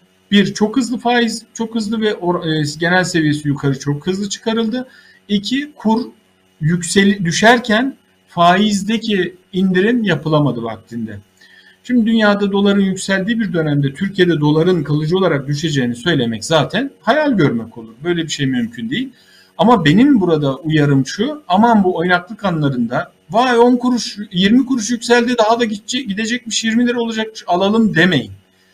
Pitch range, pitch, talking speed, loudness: 155-230 Hz, 195 Hz, 140 wpm, -15 LUFS